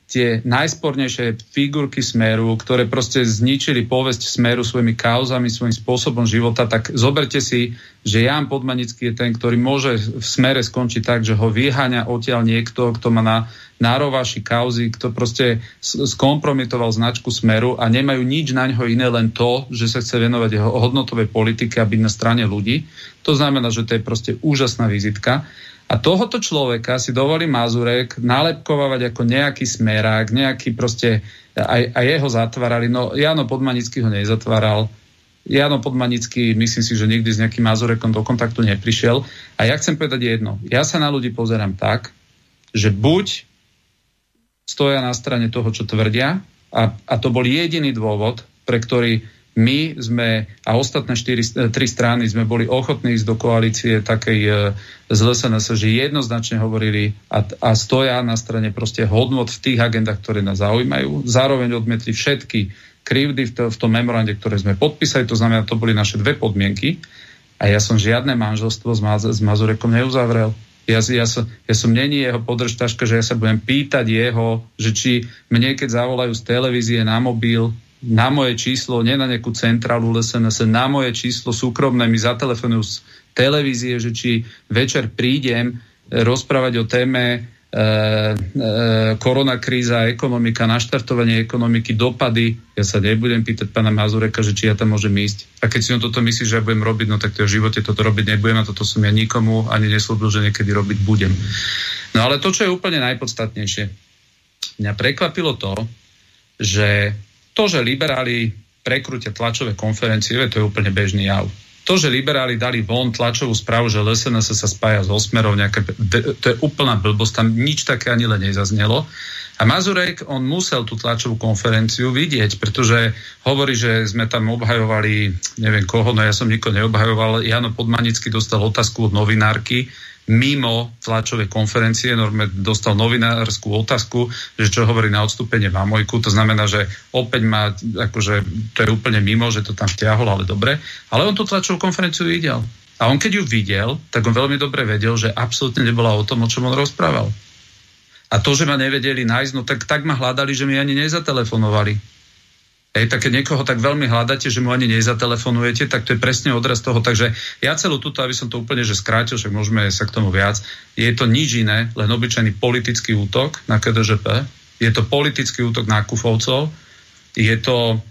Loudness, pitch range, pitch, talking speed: -17 LUFS, 110-125 Hz, 115 Hz, 170 wpm